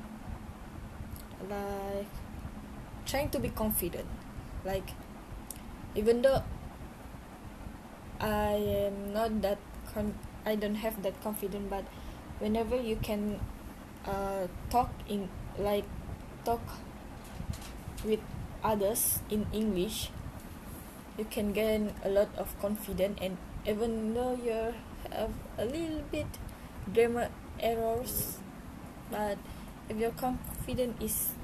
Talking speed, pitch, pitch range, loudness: 100 wpm, 210 Hz, 195-220 Hz, -34 LUFS